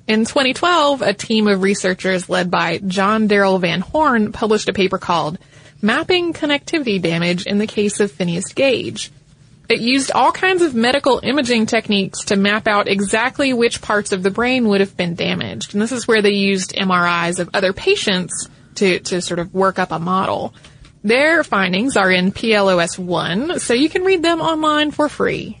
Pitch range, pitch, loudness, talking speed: 185-250 Hz, 205 Hz, -16 LUFS, 185 wpm